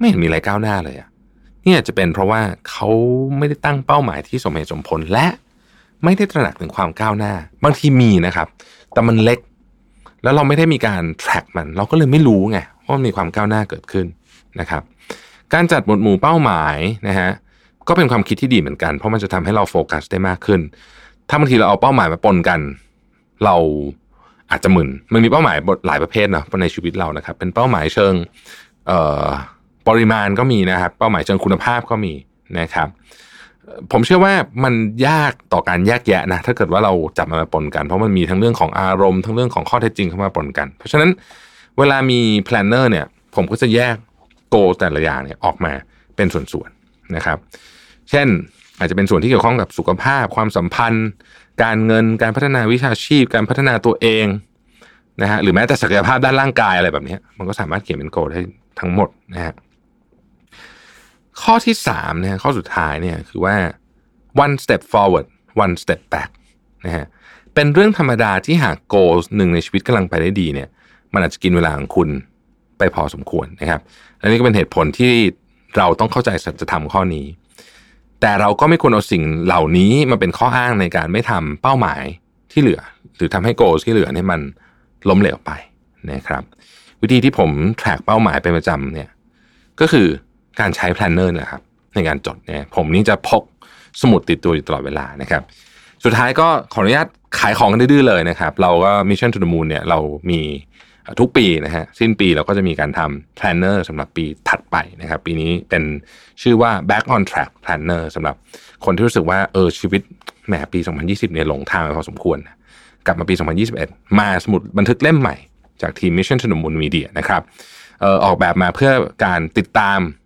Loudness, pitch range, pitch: -16 LUFS, 85-120 Hz, 100 Hz